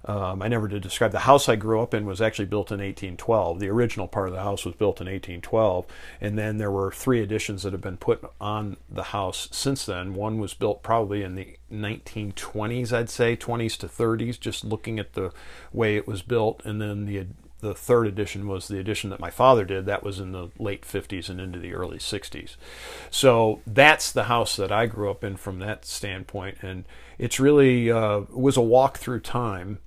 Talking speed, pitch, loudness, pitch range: 215 wpm, 105 Hz, -25 LUFS, 95-115 Hz